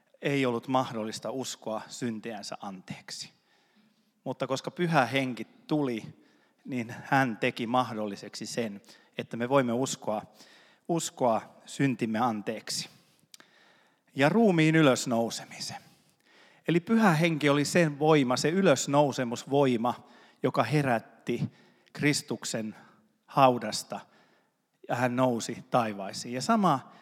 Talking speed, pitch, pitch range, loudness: 100 wpm, 130 Hz, 120-150 Hz, -28 LUFS